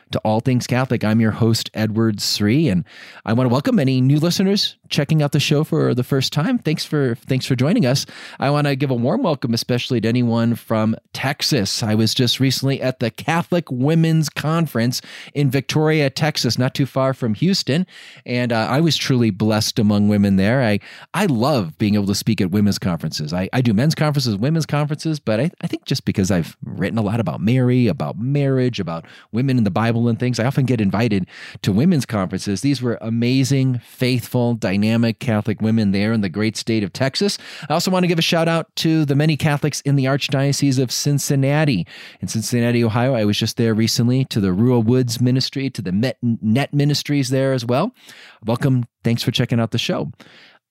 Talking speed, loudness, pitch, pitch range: 205 wpm, -19 LUFS, 125 Hz, 110-145 Hz